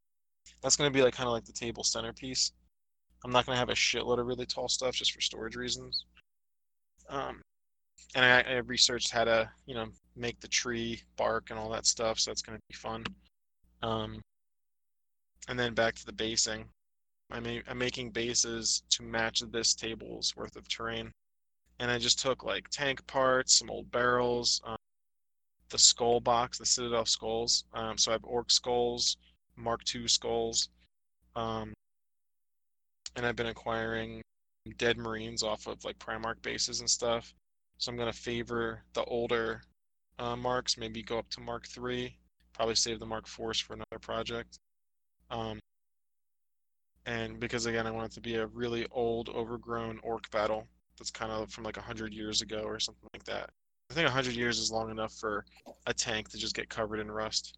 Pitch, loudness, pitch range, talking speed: 115 Hz, -31 LUFS, 110-120 Hz, 180 wpm